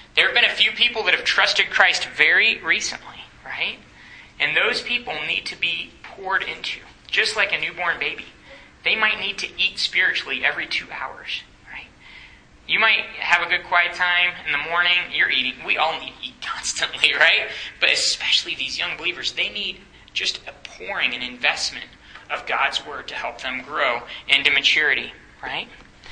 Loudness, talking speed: -20 LUFS, 175 wpm